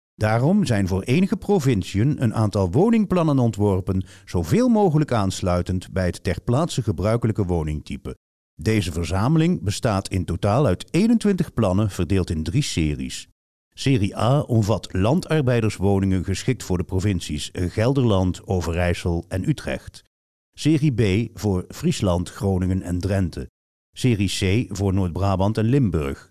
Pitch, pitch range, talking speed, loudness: 100 Hz, 90-125 Hz, 125 wpm, -22 LUFS